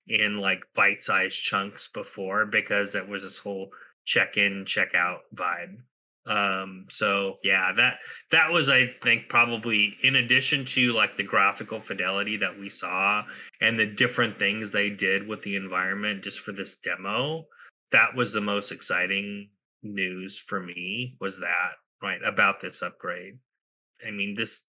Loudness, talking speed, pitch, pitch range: -25 LUFS, 160 wpm, 100 Hz, 100-110 Hz